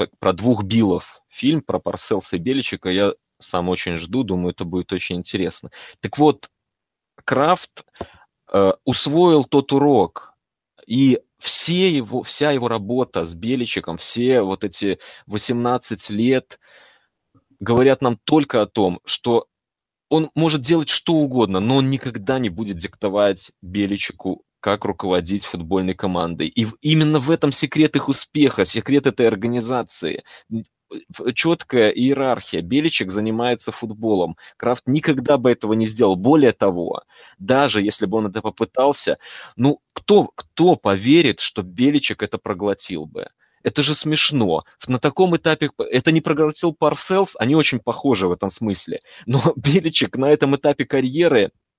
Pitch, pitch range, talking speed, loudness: 125 Hz, 105-150 Hz, 140 wpm, -19 LUFS